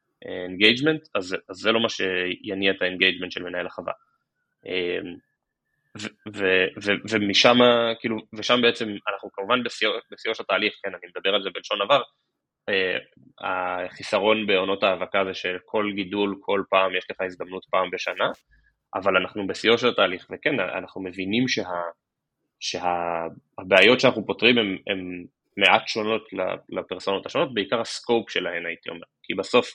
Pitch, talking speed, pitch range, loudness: 100 Hz, 140 wpm, 90-110 Hz, -23 LUFS